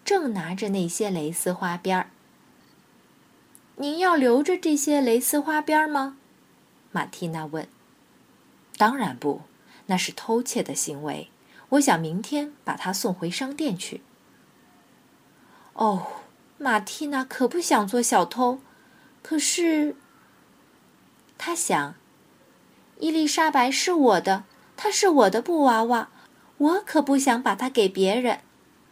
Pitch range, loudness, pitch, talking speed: 210-300 Hz, -24 LUFS, 255 Hz, 170 characters per minute